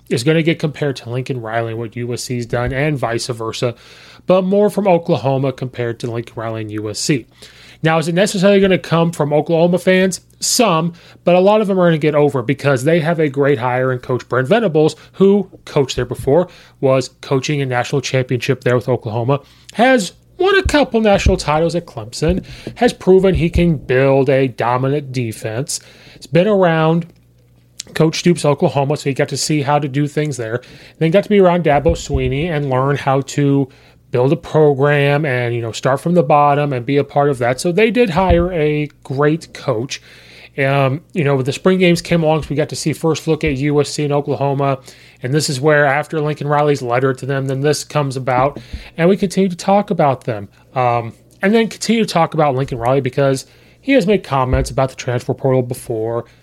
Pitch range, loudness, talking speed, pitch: 130-170 Hz, -16 LUFS, 205 wpm, 145 Hz